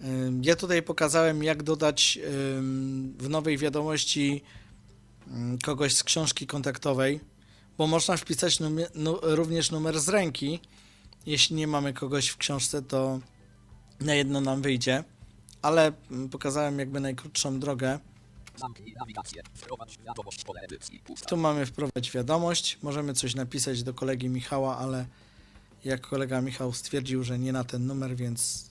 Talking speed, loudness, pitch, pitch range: 120 wpm, -28 LUFS, 135 Hz, 125-150 Hz